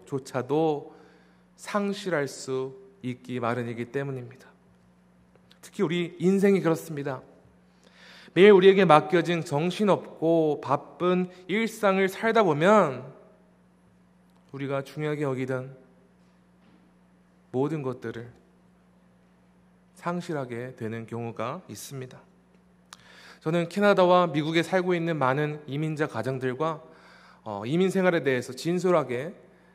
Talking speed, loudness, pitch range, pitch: 230 characters per minute, -25 LUFS, 115-175 Hz, 140 Hz